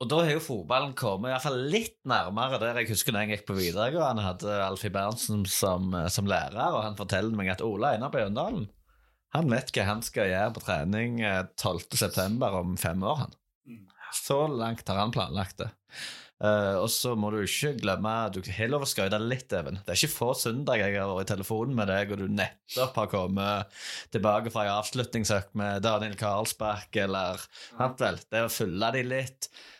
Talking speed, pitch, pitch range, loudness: 205 wpm, 105 Hz, 100-115 Hz, -29 LUFS